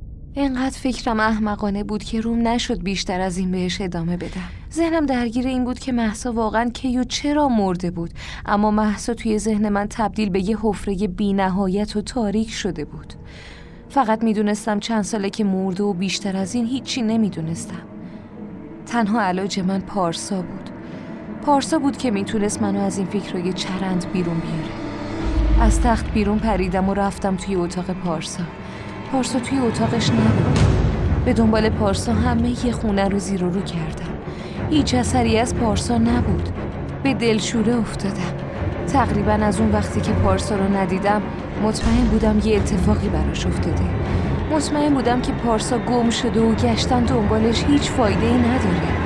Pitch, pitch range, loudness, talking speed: 205 Hz, 185-230 Hz, -21 LUFS, 155 wpm